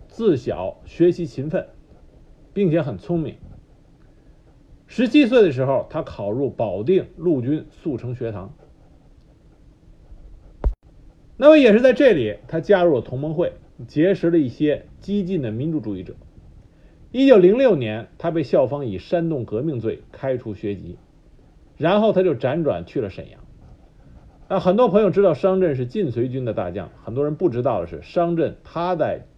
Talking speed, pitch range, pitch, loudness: 230 characters per minute, 115-185 Hz, 155 Hz, -20 LUFS